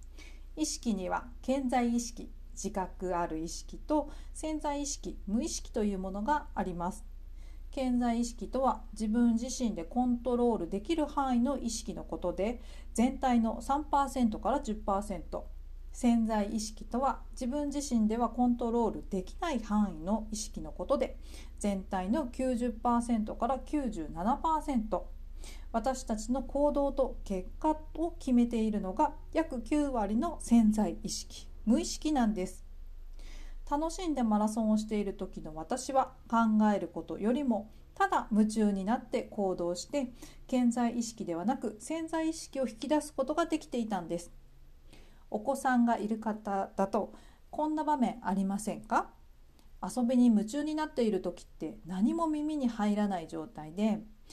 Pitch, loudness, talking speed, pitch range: 230 Hz, -32 LUFS, 280 characters per minute, 195-265 Hz